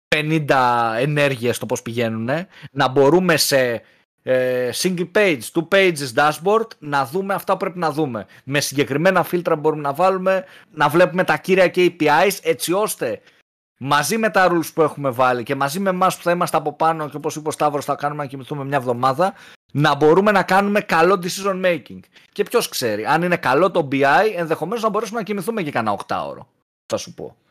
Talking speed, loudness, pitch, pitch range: 195 wpm, -19 LUFS, 160 Hz, 140-190 Hz